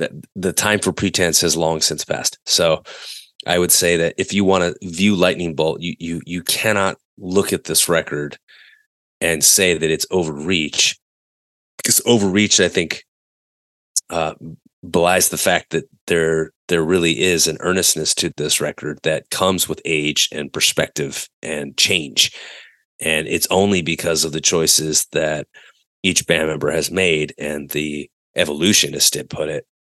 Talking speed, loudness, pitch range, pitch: 155 wpm, -17 LUFS, 80-95 Hz, 85 Hz